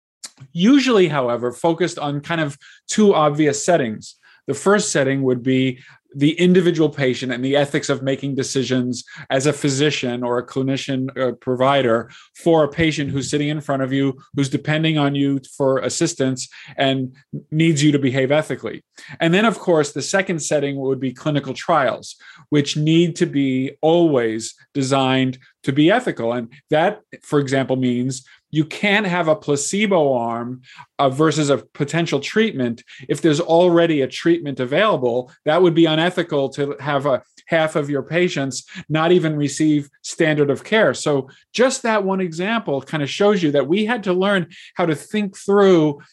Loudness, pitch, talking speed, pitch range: -19 LUFS, 145 Hz, 170 wpm, 135-170 Hz